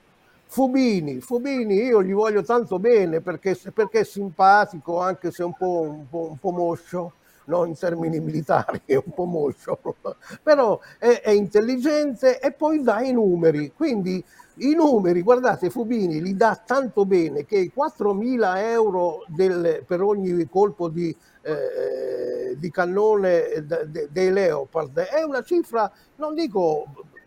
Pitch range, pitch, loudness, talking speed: 175-265 Hz, 205 Hz, -22 LUFS, 150 wpm